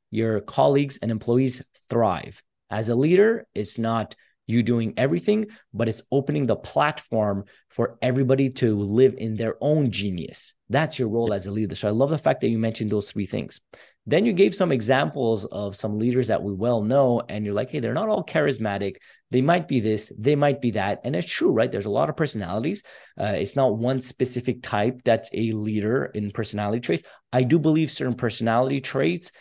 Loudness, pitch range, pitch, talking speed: -24 LUFS, 110-135 Hz, 120 Hz, 200 wpm